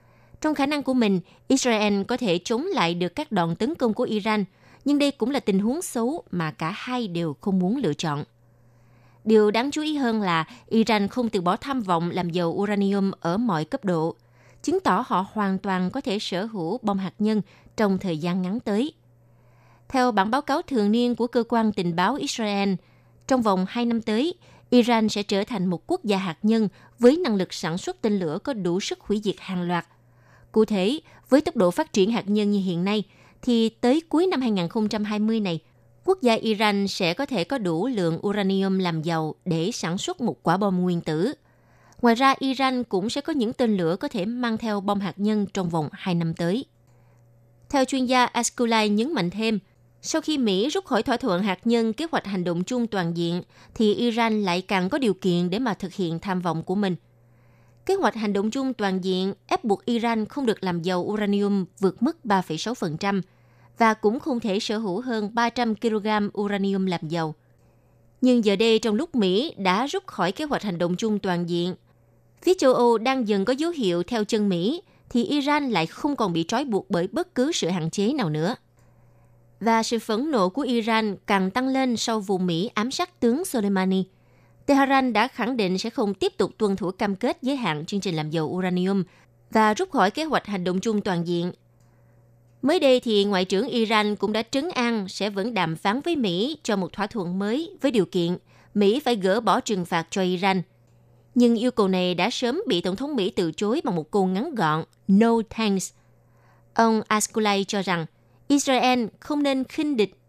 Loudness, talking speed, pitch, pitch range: -24 LUFS, 210 wpm, 205 Hz, 180-235 Hz